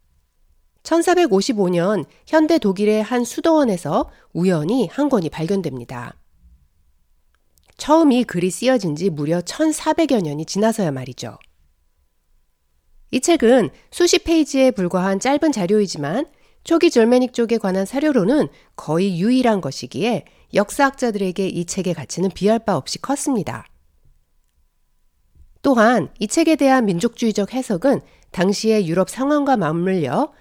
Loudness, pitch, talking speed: -18 LUFS, 200 Hz, 260 characters per minute